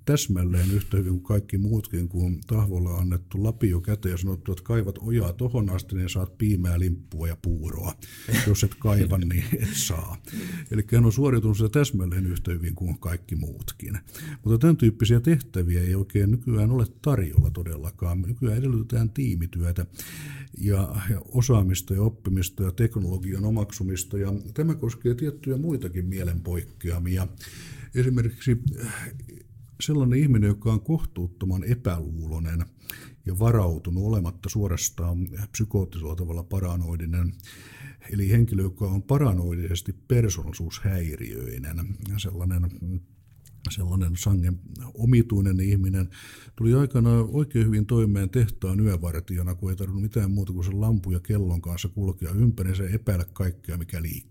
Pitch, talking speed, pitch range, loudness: 100 Hz, 130 wpm, 90-115 Hz, -26 LUFS